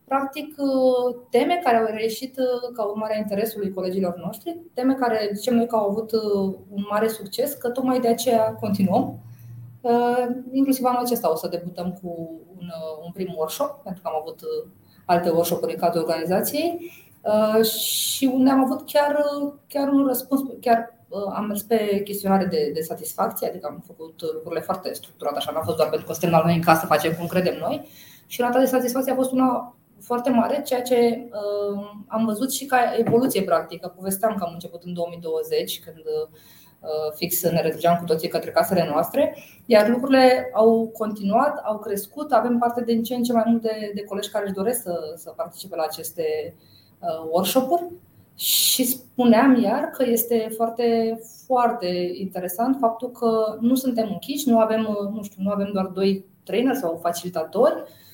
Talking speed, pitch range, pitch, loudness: 175 wpm, 180-250 Hz, 220 Hz, -23 LUFS